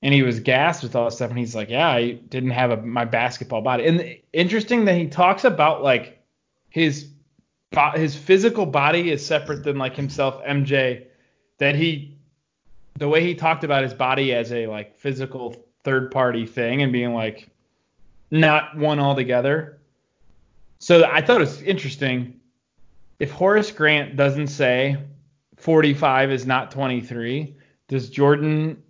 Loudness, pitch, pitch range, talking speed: -20 LUFS, 140 Hz, 125-155 Hz, 160 wpm